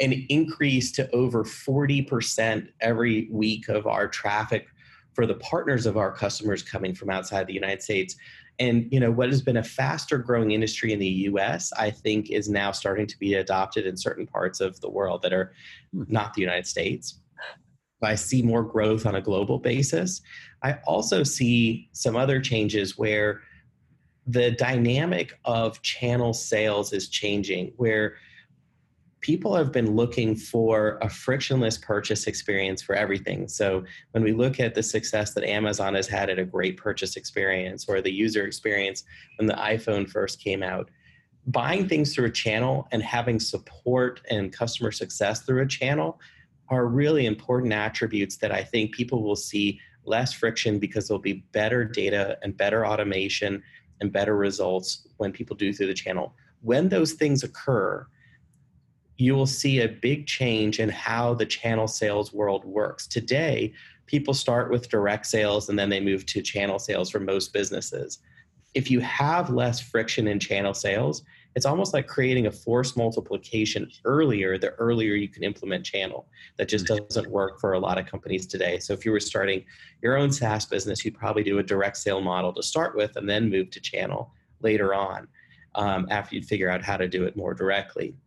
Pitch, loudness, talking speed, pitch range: 110 Hz, -26 LUFS, 175 wpm, 100-125 Hz